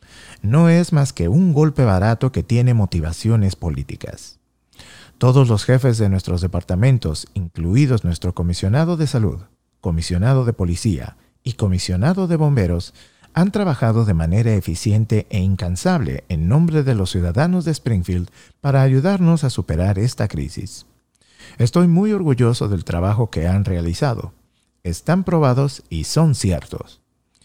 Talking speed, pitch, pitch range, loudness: 135 wpm, 110 Hz, 90-140 Hz, -18 LUFS